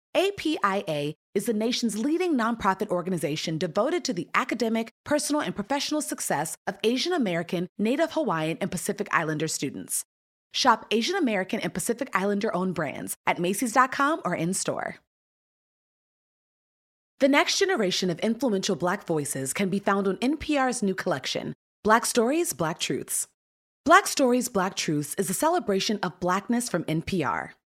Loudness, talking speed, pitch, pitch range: -26 LUFS, 140 wpm, 205 Hz, 180-260 Hz